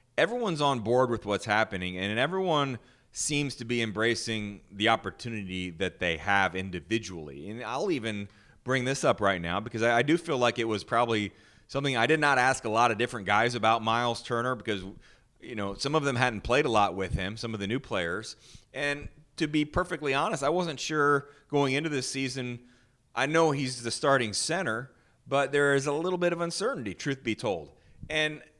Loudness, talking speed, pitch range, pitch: -28 LUFS, 195 wpm, 110-140 Hz, 120 Hz